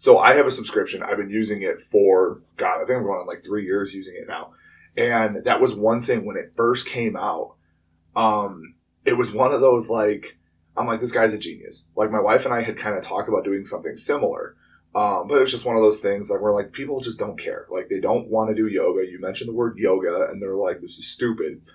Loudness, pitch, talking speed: -22 LUFS, 115 Hz, 250 wpm